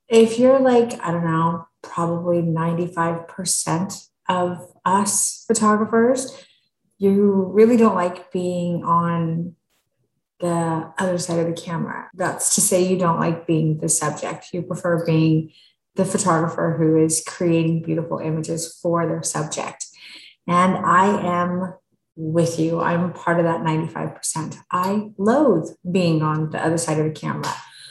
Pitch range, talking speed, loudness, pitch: 165-190 Hz, 140 wpm, -20 LUFS, 175 Hz